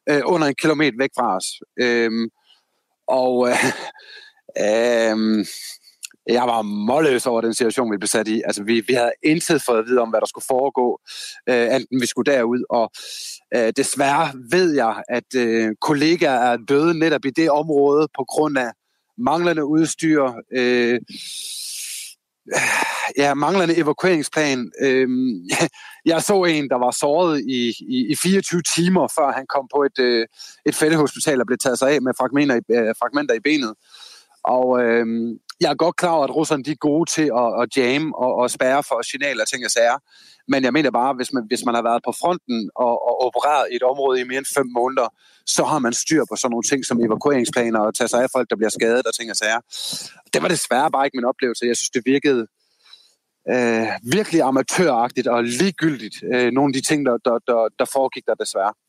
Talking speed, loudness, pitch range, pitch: 195 wpm, -19 LUFS, 120-155 Hz, 130 Hz